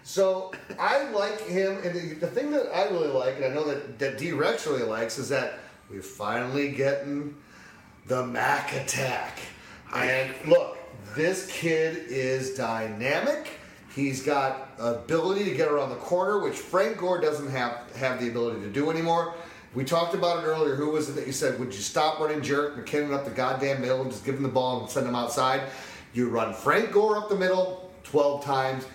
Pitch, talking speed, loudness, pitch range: 145 Hz, 195 wpm, -27 LUFS, 130-175 Hz